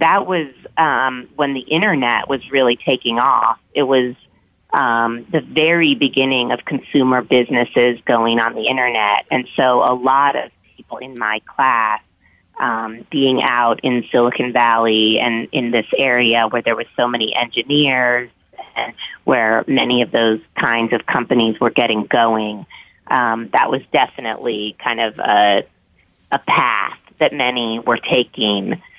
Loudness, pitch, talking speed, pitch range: -16 LUFS, 120 Hz, 150 wpm, 115-135 Hz